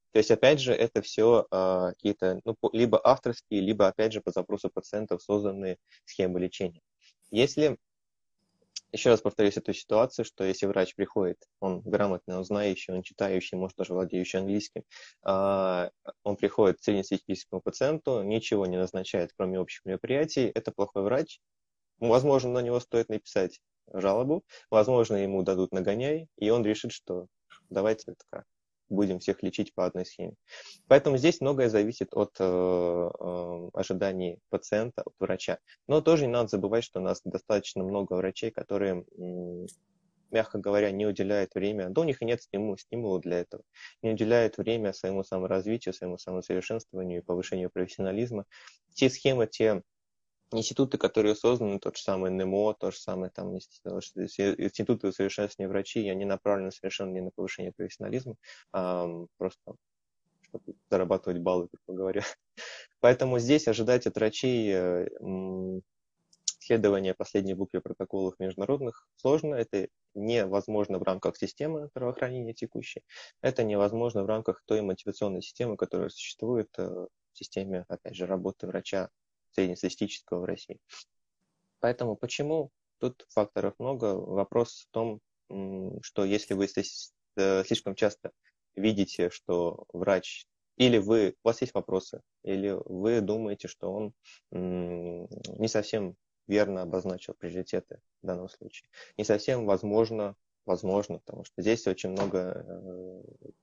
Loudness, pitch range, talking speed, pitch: -30 LUFS, 95-110 Hz, 135 wpm, 100 Hz